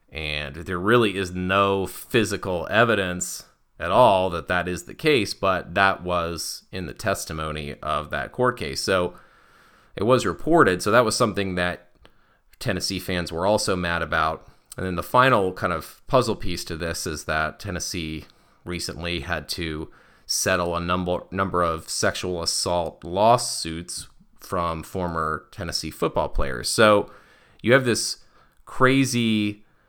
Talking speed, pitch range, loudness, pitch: 145 wpm, 85-100 Hz, -23 LUFS, 90 Hz